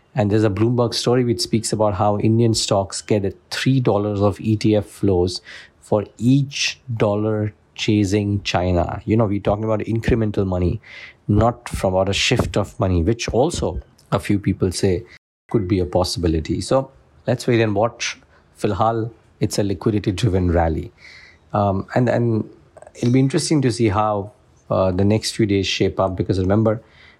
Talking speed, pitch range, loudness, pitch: 165 wpm, 95-115 Hz, -20 LUFS, 105 Hz